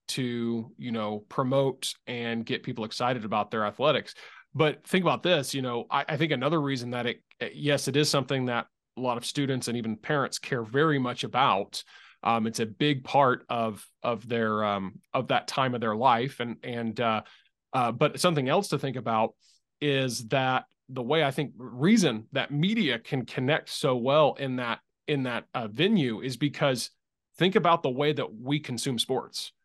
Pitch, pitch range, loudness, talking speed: 130 Hz, 115-145 Hz, -28 LUFS, 190 wpm